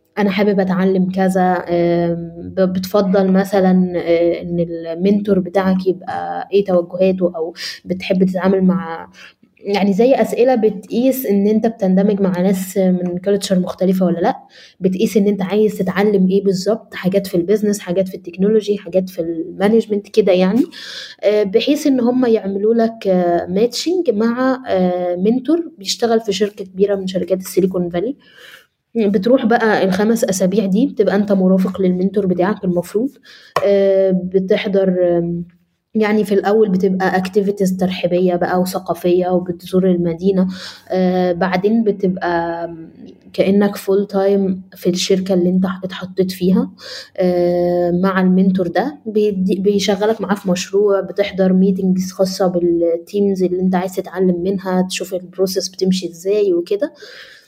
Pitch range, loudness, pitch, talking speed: 180-205 Hz, -16 LUFS, 190 Hz, 125 wpm